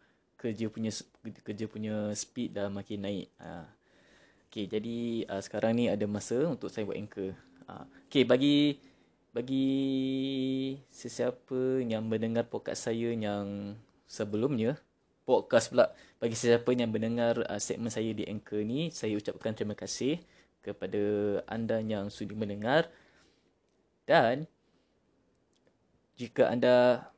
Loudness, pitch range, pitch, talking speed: -31 LUFS, 105-120 Hz, 110 Hz, 120 wpm